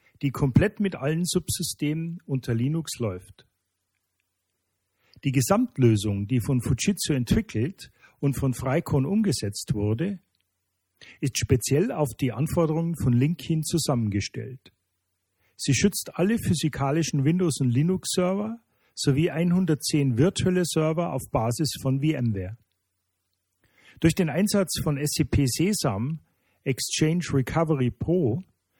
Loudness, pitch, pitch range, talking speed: -25 LUFS, 140 Hz, 110-165 Hz, 105 wpm